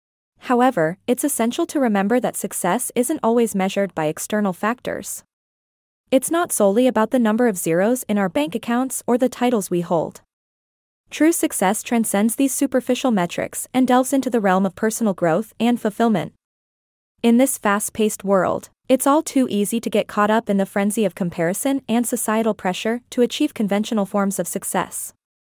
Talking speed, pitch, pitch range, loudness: 170 wpm, 225 Hz, 200-250 Hz, -20 LUFS